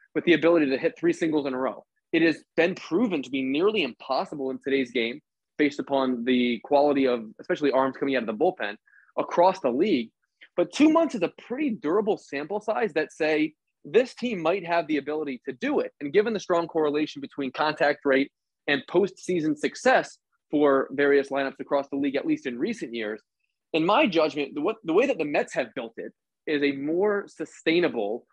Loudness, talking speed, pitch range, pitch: -25 LUFS, 195 wpm, 140-185 Hz, 155 Hz